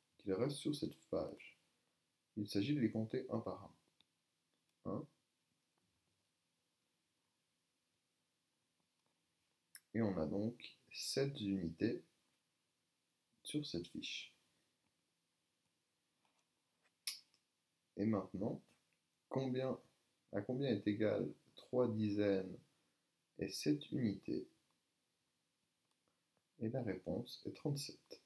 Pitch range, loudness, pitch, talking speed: 95-130 Hz, -42 LUFS, 105 Hz, 85 wpm